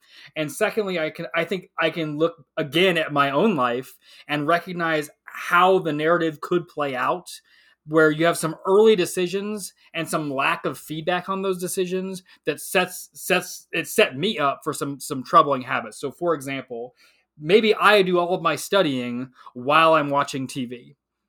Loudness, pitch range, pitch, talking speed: -22 LUFS, 145-185 Hz, 165 Hz, 175 wpm